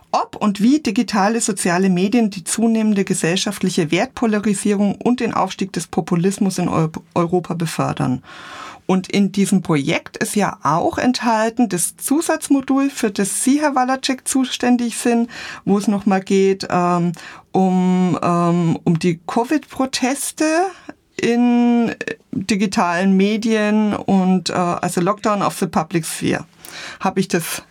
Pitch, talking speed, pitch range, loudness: 205 Hz, 130 wpm, 185-240 Hz, -18 LUFS